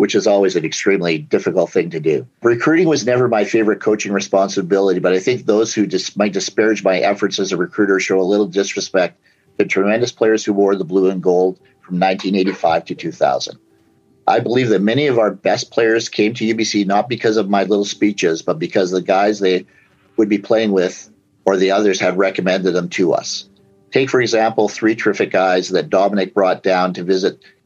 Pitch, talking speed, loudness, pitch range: 100 Hz, 205 wpm, -16 LUFS, 95-105 Hz